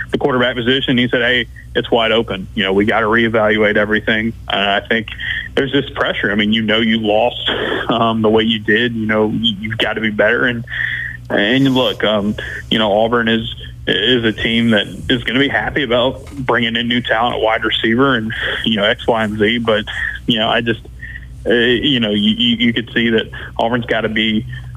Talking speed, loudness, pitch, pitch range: 215 wpm, -15 LUFS, 110 Hz, 105-120 Hz